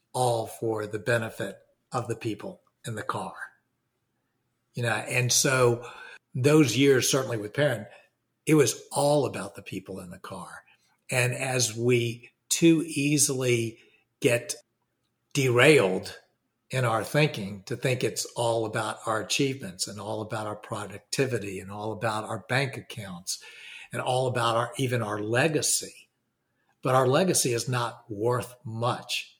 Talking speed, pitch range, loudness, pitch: 145 wpm, 110-130 Hz, -26 LUFS, 120 Hz